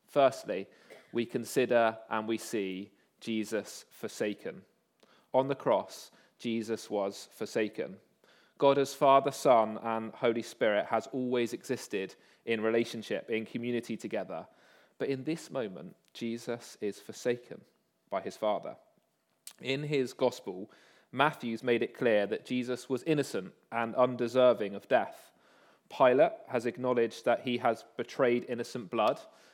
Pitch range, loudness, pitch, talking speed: 115-125 Hz, -32 LUFS, 120 Hz, 130 wpm